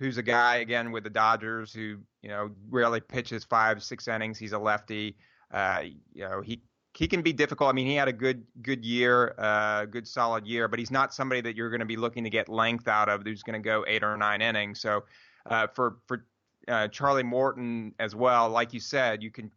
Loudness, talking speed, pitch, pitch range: -28 LUFS, 230 wpm, 115 Hz, 110-125 Hz